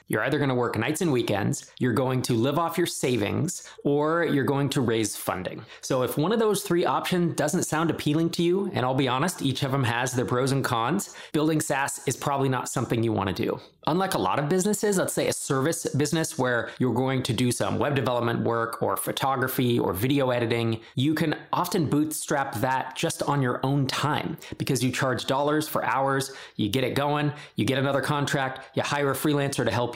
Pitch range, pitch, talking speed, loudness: 125-155 Hz, 140 Hz, 220 wpm, -26 LUFS